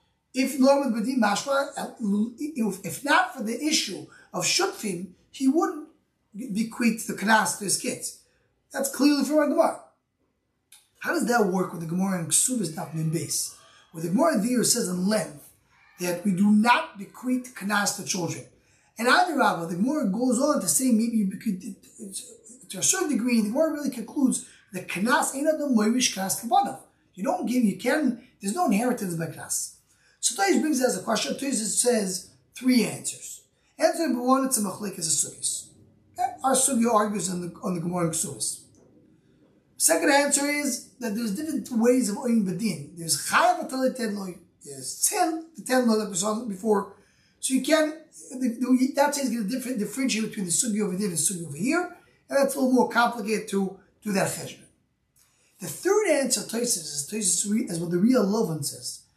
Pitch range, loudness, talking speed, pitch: 200-265 Hz, -25 LUFS, 180 wpm, 230 Hz